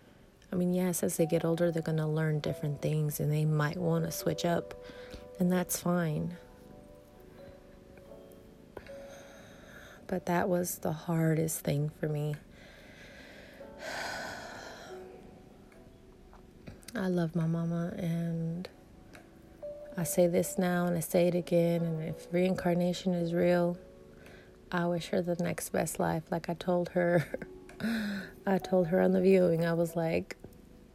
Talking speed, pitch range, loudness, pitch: 135 wpm, 160-180 Hz, -31 LUFS, 175 Hz